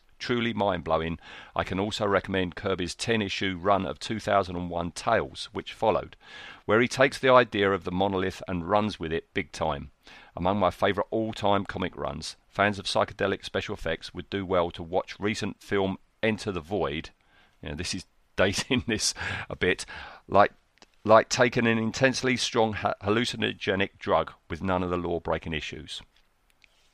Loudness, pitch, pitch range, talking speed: -27 LUFS, 100 Hz, 90-110 Hz, 170 wpm